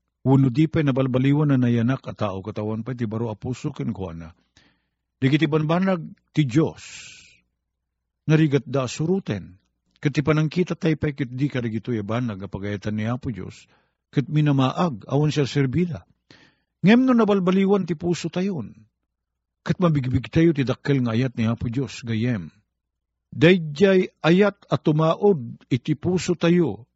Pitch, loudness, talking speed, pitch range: 135 Hz, -22 LUFS, 145 wpm, 115-165 Hz